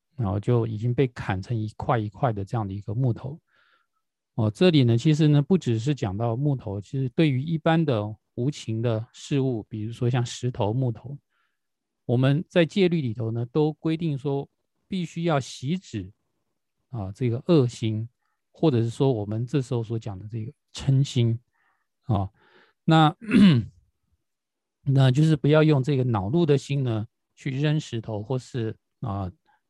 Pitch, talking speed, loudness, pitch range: 125 Hz, 230 characters per minute, -25 LUFS, 110-150 Hz